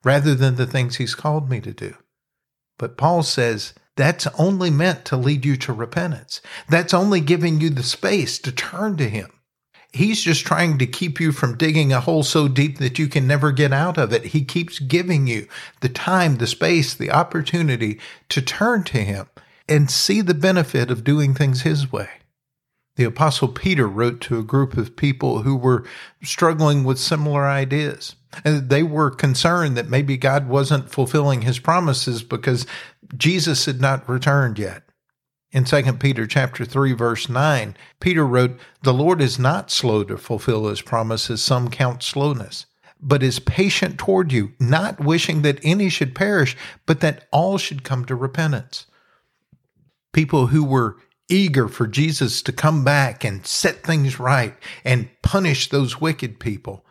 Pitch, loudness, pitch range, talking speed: 140 Hz, -19 LUFS, 125-155 Hz, 170 wpm